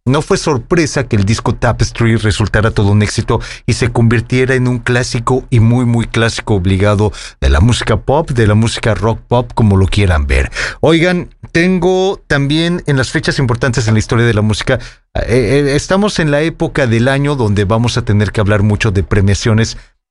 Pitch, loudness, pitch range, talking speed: 120 Hz, -13 LUFS, 110-135 Hz, 195 wpm